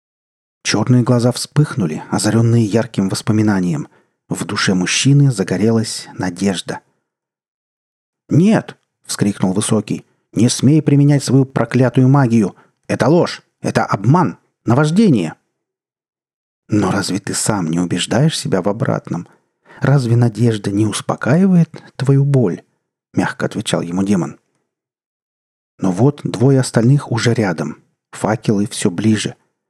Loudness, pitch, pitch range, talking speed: -16 LUFS, 115 Hz, 100-135 Hz, 105 wpm